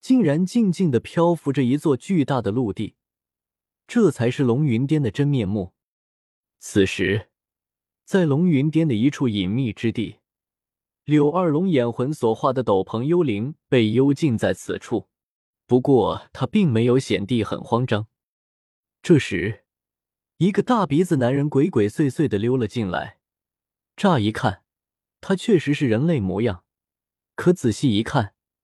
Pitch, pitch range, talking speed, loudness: 130 Hz, 105-155 Hz, 210 characters per minute, -21 LUFS